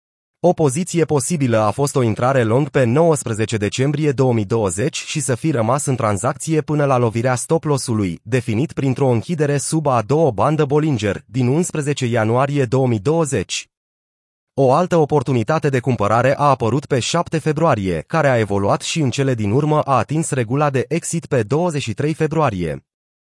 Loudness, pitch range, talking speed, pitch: -18 LUFS, 120-155 Hz, 155 wpm, 135 Hz